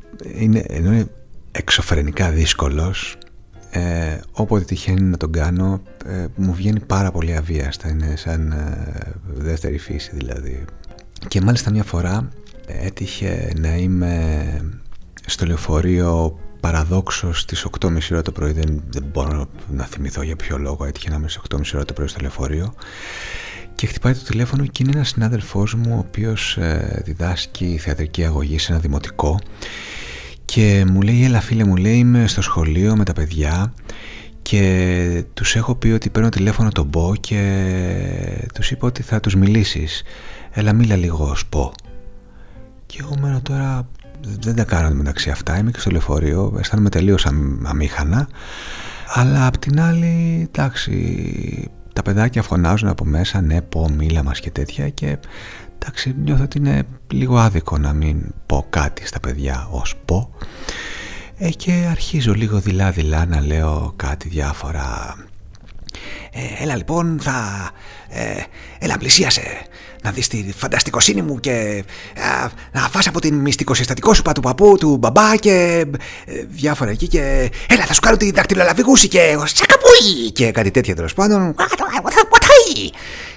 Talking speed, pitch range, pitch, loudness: 145 wpm, 80-115 Hz, 95 Hz, -17 LUFS